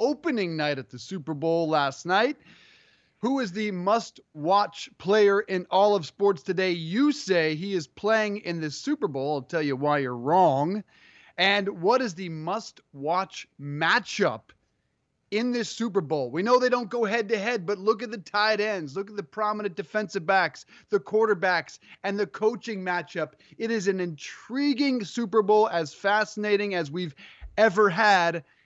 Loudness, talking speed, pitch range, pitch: -26 LUFS, 175 wpm, 170-220 Hz, 200 Hz